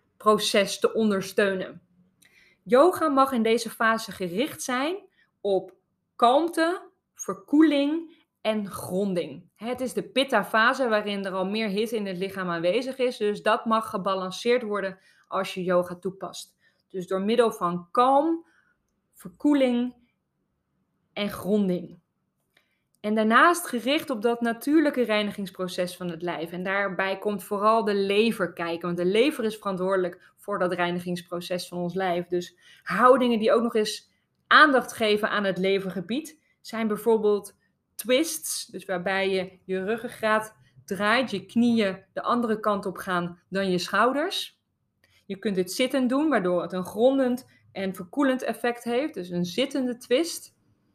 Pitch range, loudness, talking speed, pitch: 185-245 Hz, -25 LUFS, 145 wpm, 210 Hz